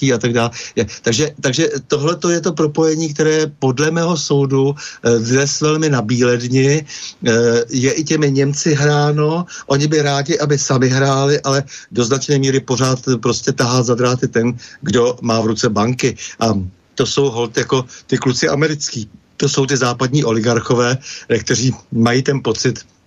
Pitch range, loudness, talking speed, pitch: 120-145 Hz, -16 LUFS, 160 wpm, 135 Hz